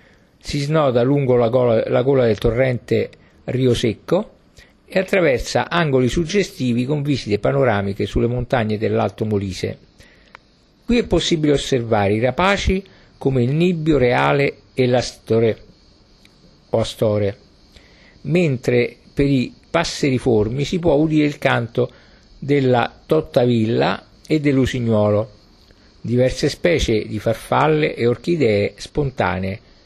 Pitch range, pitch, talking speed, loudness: 110-145 Hz, 125 Hz, 110 wpm, -19 LUFS